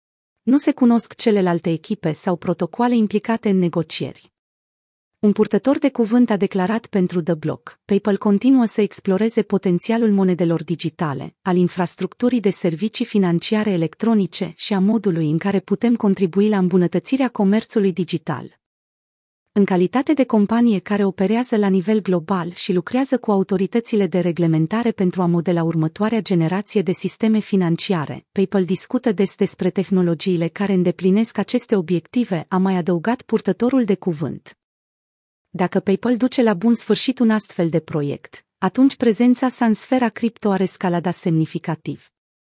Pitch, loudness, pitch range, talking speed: 195 Hz, -19 LUFS, 180-220 Hz, 140 wpm